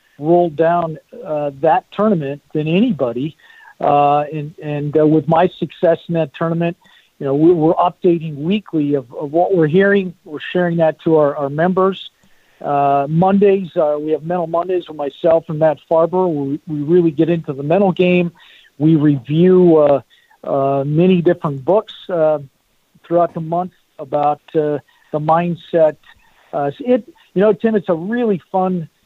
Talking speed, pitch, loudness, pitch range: 165 wpm, 165 Hz, -16 LUFS, 150-180 Hz